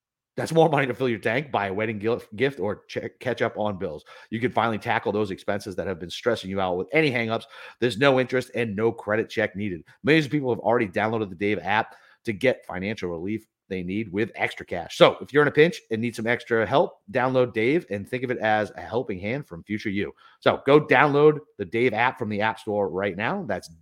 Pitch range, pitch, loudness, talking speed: 105-130 Hz, 115 Hz, -24 LUFS, 240 wpm